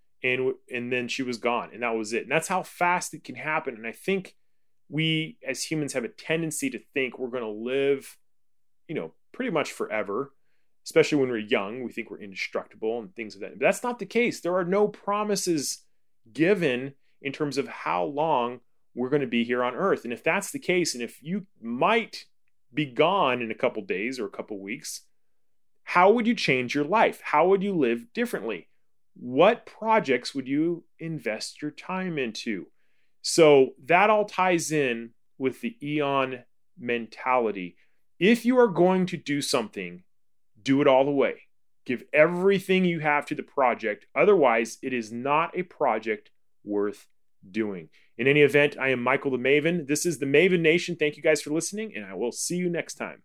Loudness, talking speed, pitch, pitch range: -25 LUFS, 195 wpm, 150 Hz, 125-180 Hz